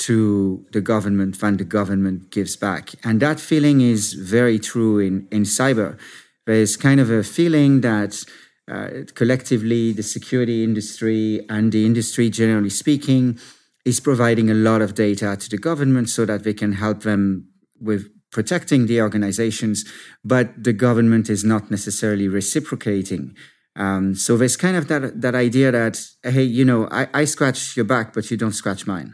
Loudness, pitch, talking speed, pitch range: -19 LUFS, 110 Hz, 165 wpm, 105-125 Hz